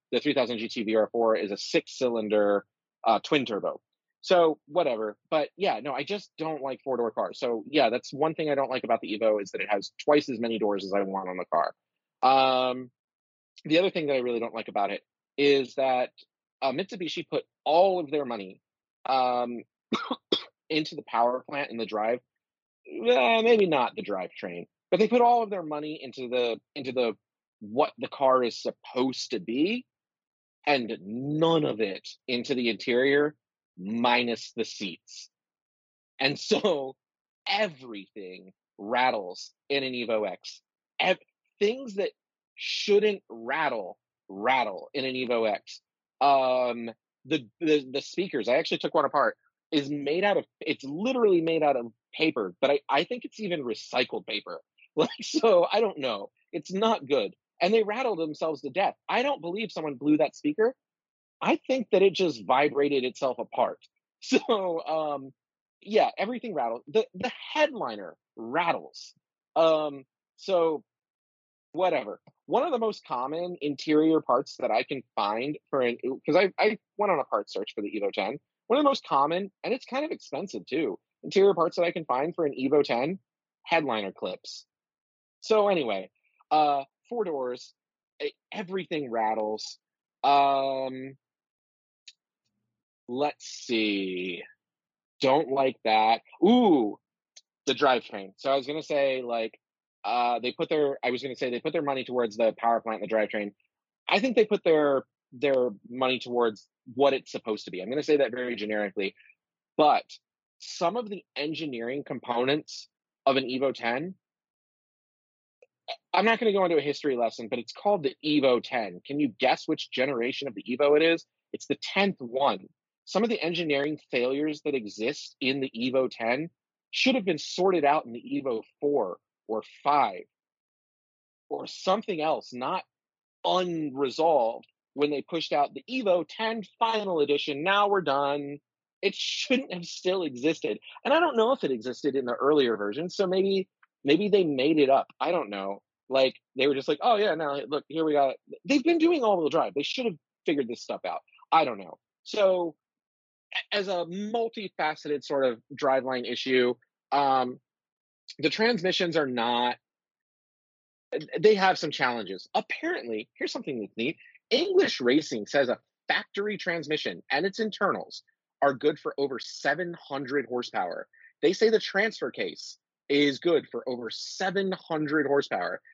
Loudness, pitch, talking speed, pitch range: -27 LUFS, 145 Hz, 165 wpm, 125-190 Hz